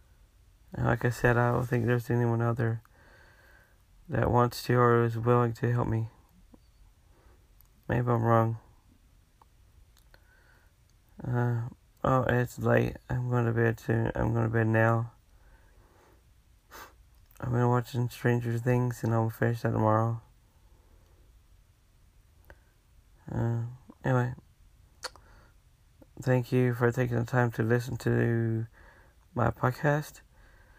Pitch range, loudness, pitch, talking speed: 95-120 Hz, -28 LUFS, 115 Hz, 115 wpm